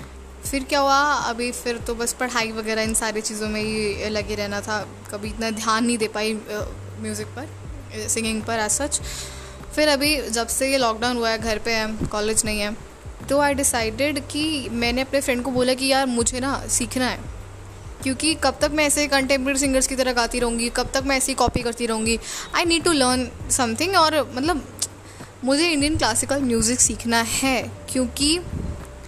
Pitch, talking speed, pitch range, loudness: 240 Hz, 190 wpm, 220-275 Hz, -21 LUFS